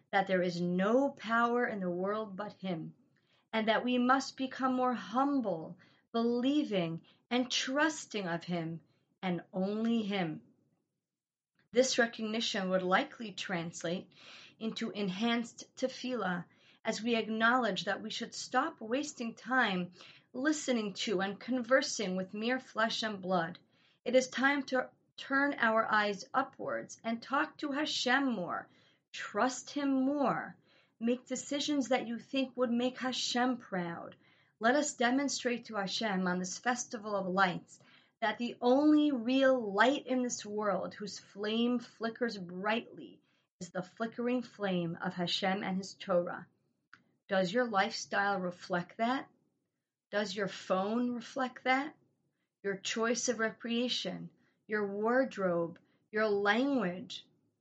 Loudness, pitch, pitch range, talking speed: -33 LUFS, 230 Hz, 195-255 Hz, 130 wpm